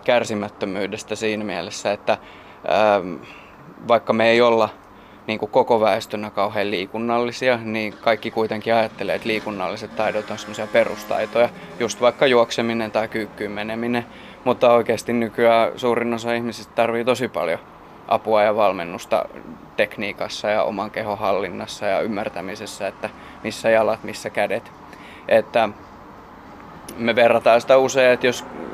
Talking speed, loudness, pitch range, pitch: 130 wpm, -21 LUFS, 105-120 Hz, 110 Hz